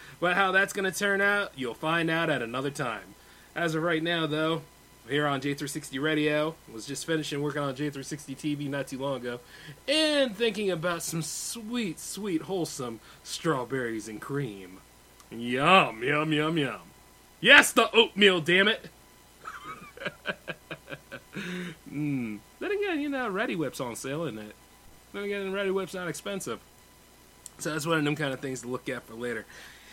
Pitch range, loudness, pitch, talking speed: 135-190 Hz, -28 LUFS, 155 Hz, 165 wpm